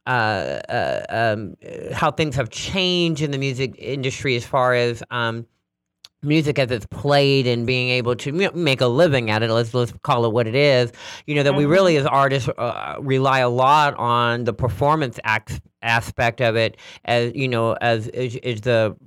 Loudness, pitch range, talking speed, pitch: -20 LUFS, 120-140 Hz, 190 wpm, 125 Hz